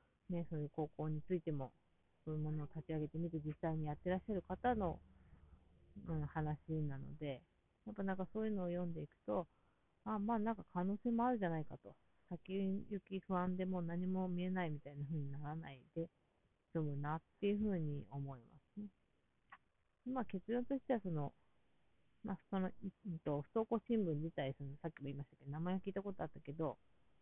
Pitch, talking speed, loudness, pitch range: 165 Hz, 355 characters per minute, -44 LUFS, 150-195 Hz